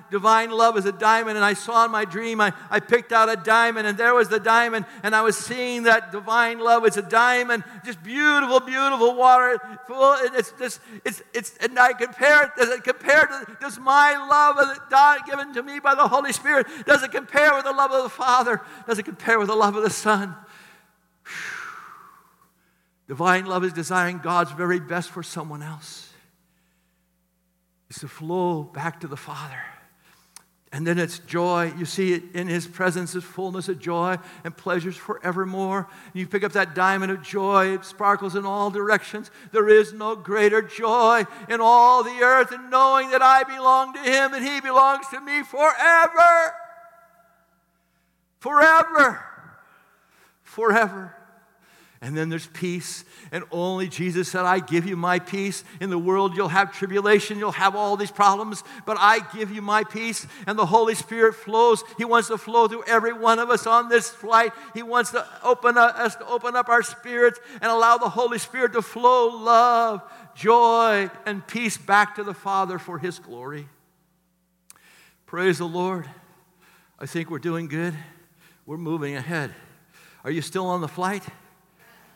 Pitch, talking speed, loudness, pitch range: 210 Hz, 180 wpm, -20 LUFS, 180-240 Hz